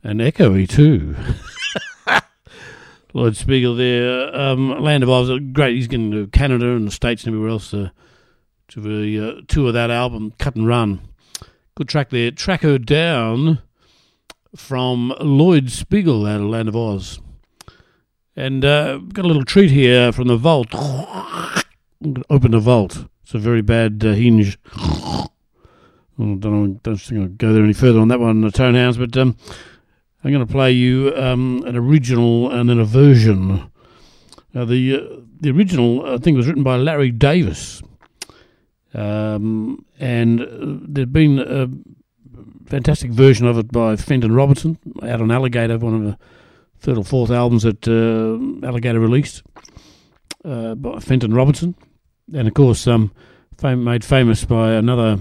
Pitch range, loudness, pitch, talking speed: 110-135 Hz, -16 LUFS, 120 Hz, 160 wpm